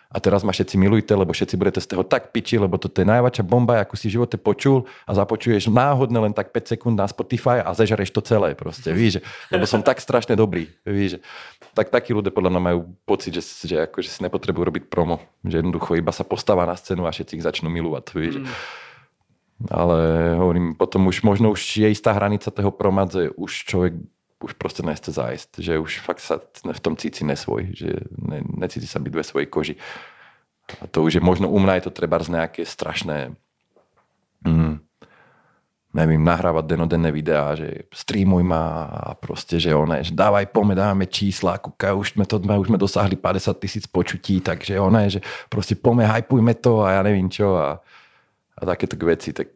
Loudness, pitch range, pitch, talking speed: -21 LUFS, 85-110 Hz, 100 Hz, 195 wpm